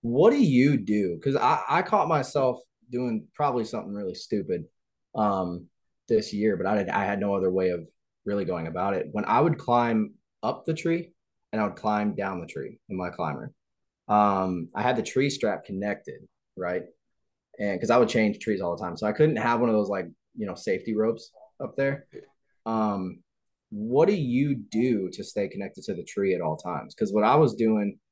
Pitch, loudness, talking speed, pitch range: 110 Hz, -26 LUFS, 205 wpm, 100-130 Hz